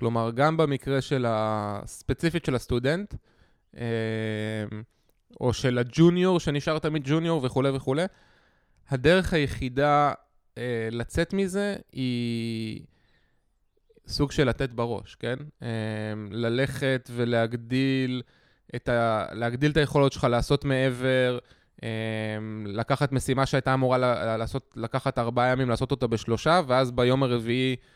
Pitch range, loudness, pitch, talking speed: 115-140 Hz, -26 LUFS, 125 Hz, 105 wpm